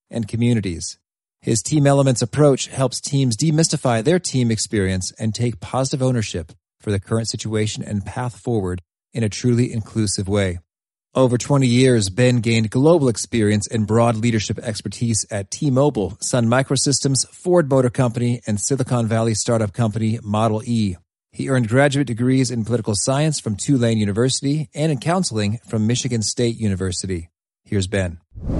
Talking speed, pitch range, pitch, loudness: 155 wpm, 105-130 Hz, 115 Hz, -19 LUFS